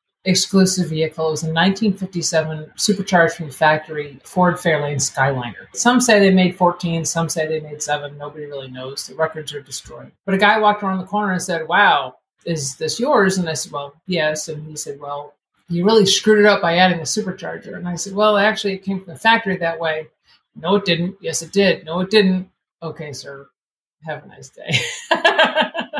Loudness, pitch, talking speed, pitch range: -18 LUFS, 170 Hz, 205 wpm, 155-195 Hz